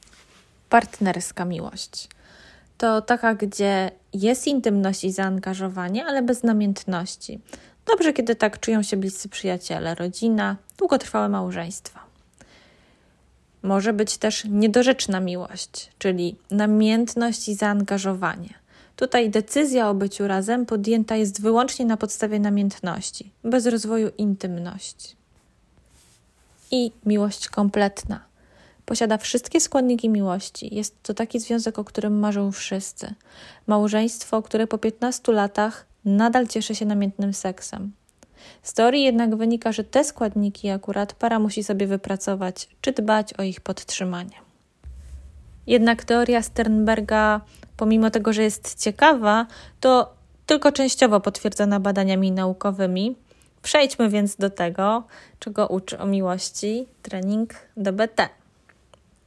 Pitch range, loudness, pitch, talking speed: 195-230 Hz, -22 LUFS, 210 Hz, 110 wpm